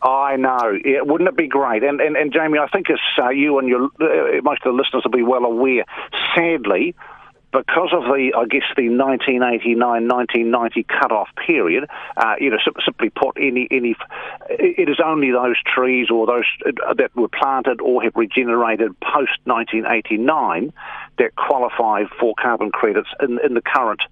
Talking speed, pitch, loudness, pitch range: 175 wpm, 135 Hz, -18 LUFS, 125-165 Hz